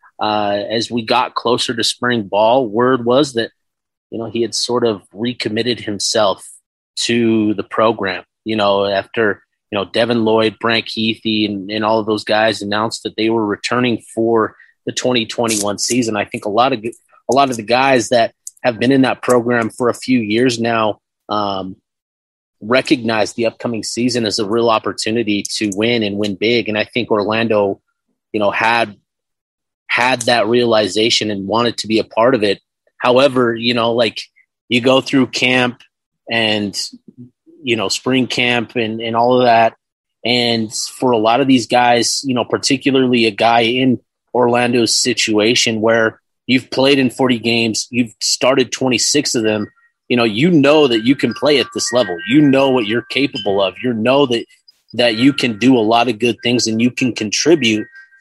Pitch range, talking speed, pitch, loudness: 110-125 Hz, 180 wpm, 115 Hz, -15 LUFS